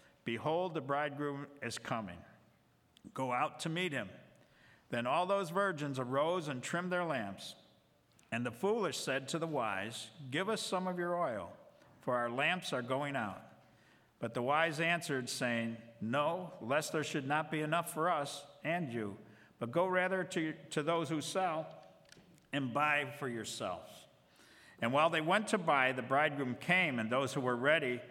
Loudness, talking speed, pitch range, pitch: -36 LUFS, 170 wpm, 130-170 Hz, 150 Hz